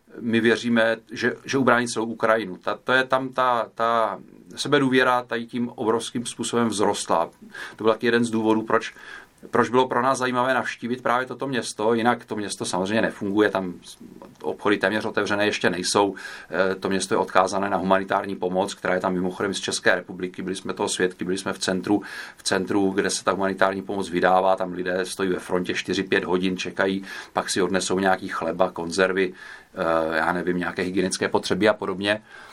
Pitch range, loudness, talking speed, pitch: 95-115 Hz, -23 LUFS, 175 wpm, 100 Hz